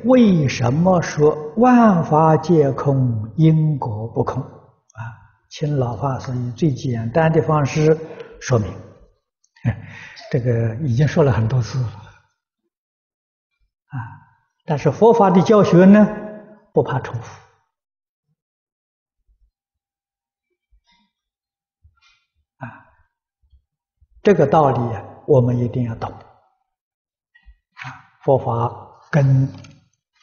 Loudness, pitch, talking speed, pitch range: -17 LUFS, 150 Hz, 125 characters per minute, 120-190 Hz